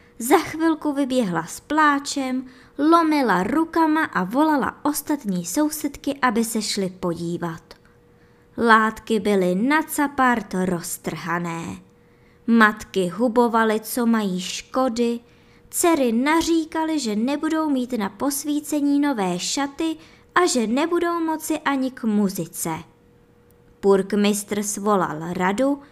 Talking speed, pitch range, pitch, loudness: 100 wpm, 200-295 Hz, 250 Hz, -21 LUFS